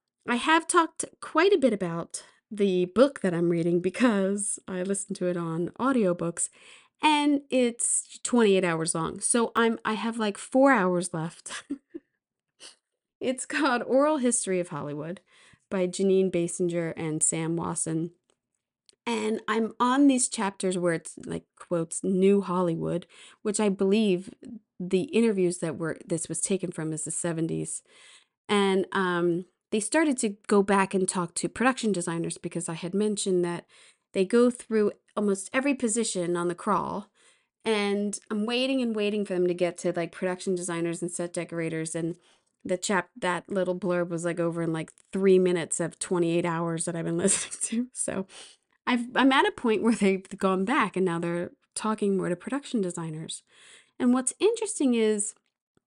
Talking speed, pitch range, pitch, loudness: 165 wpm, 175-230 Hz, 195 Hz, -27 LUFS